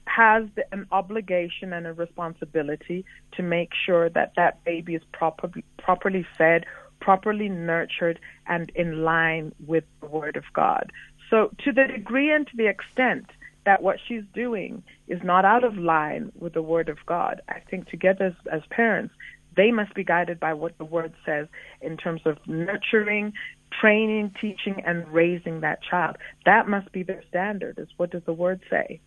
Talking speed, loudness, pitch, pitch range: 170 wpm, -24 LUFS, 180 Hz, 165-210 Hz